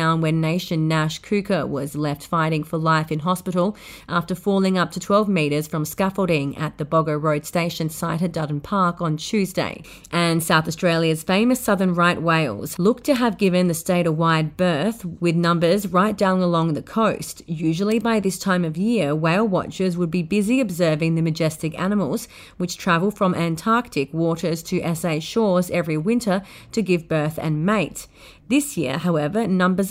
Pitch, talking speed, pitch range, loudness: 175 Hz, 175 wpm, 160-195 Hz, -21 LUFS